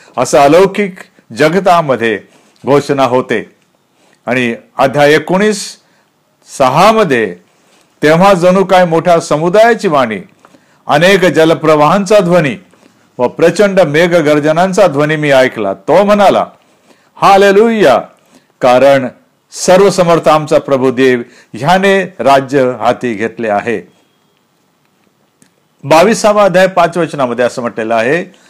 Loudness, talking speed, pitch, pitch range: -9 LUFS, 95 wpm, 160 Hz, 130-190 Hz